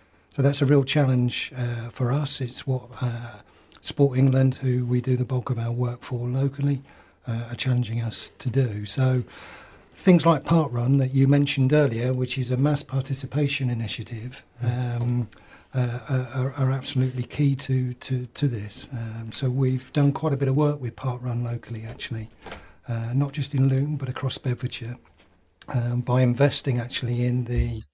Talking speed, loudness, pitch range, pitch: 175 wpm, -25 LUFS, 120-135 Hz, 125 Hz